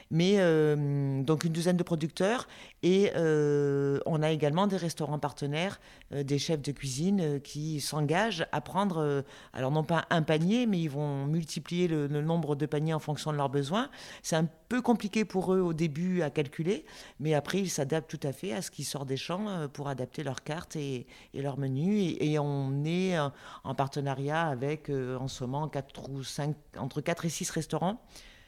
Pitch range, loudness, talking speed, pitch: 140-175 Hz, -31 LUFS, 200 wpm, 155 Hz